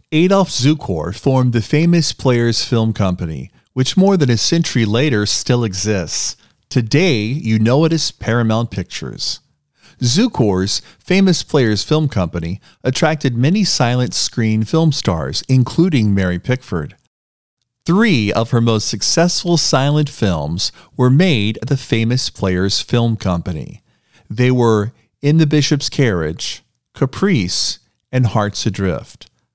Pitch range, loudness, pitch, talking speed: 105-145 Hz, -16 LUFS, 120 Hz, 125 wpm